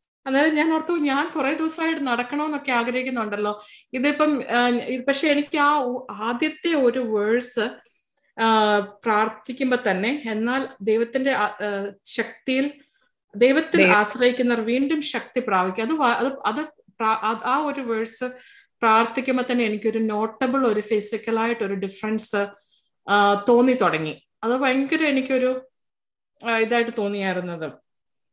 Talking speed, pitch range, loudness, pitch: 95 wpm, 220-270 Hz, -22 LUFS, 240 Hz